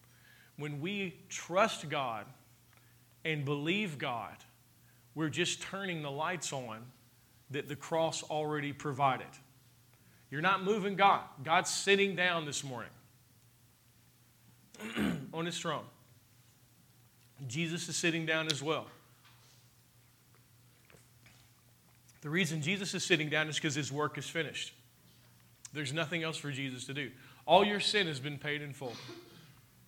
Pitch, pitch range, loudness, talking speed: 140 Hz, 120-160 Hz, -34 LUFS, 125 wpm